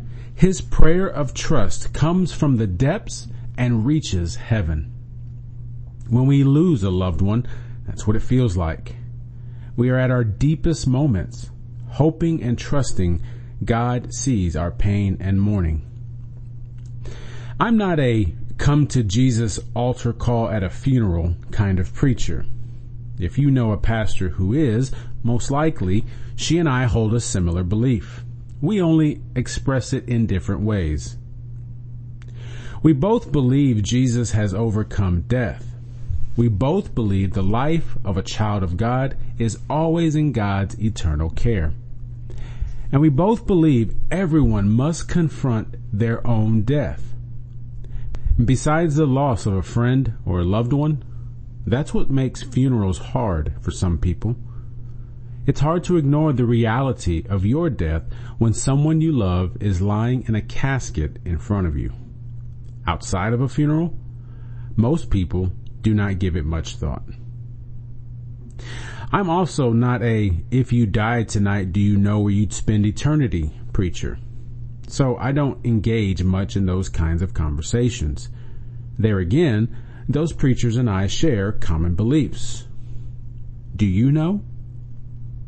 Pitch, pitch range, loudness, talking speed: 120 Hz, 110-125 Hz, -21 LUFS, 140 wpm